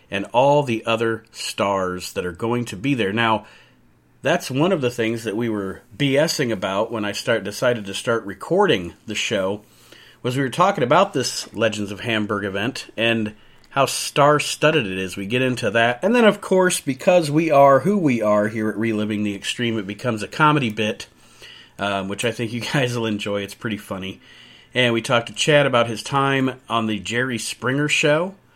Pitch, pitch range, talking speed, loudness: 115 Hz, 105-140 Hz, 200 wpm, -20 LUFS